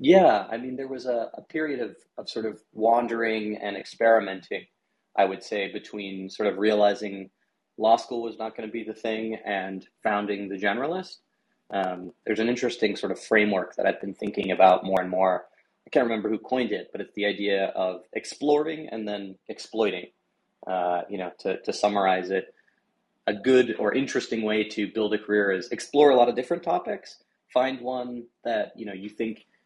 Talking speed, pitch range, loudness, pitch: 190 wpm, 100-120 Hz, -26 LUFS, 110 Hz